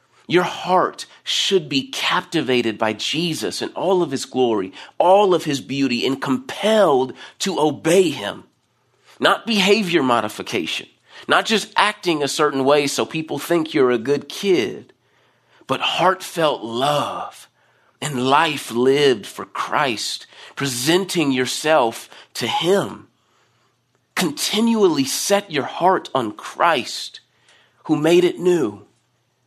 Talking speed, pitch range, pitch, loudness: 120 wpm, 135-190 Hz, 155 Hz, -19 LUFS